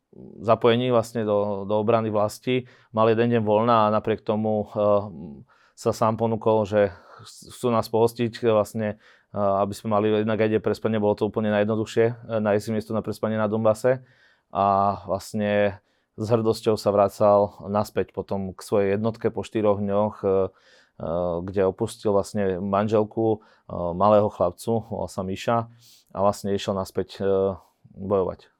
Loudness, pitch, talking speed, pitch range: -24 LUFS, 105 Hz, 155 wpm, 100-110 Hz